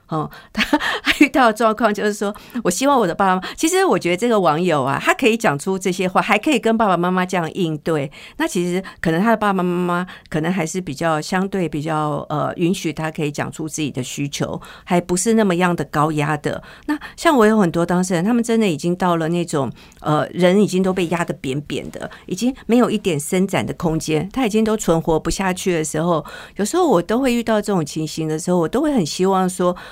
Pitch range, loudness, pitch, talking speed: 160-215 Hz, -19 LUFS, 180 Hz, 340 characters per minute